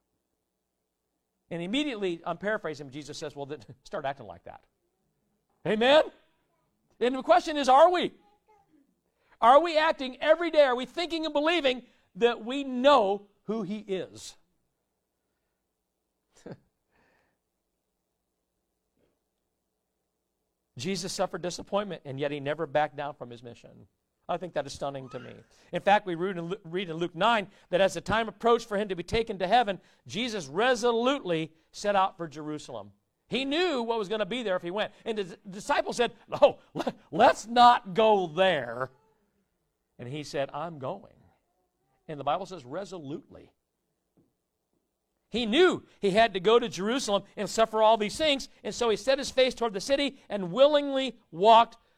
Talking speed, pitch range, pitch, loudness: 155 wpm, 170-250 Hz, 210 Hz, -27 LUFS